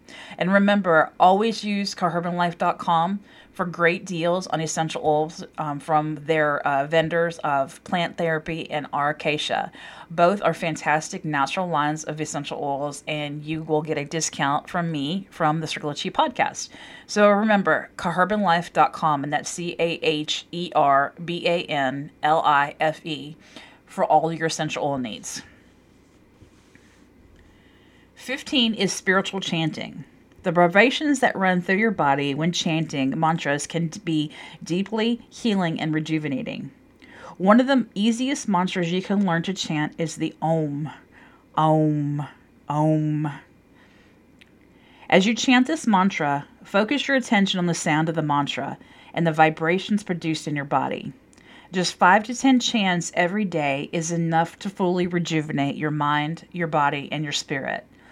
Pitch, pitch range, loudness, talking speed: 165 Hz, 150-190 Hz, -23 LUFS, 135 wpm